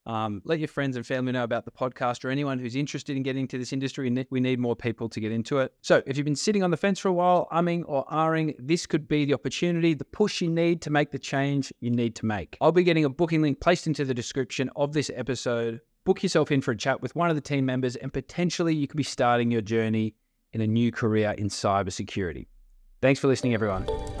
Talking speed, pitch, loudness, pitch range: 250 wpm, 135 Hz, -26 LUFS, 120-155 Hz